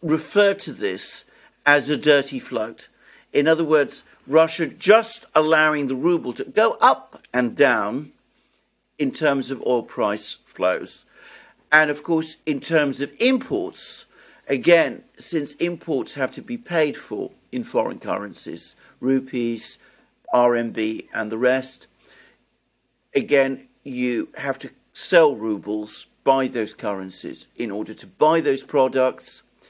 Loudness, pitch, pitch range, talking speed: -21 LUFS, 140 Hz, 125-160 Hz, 130 wpm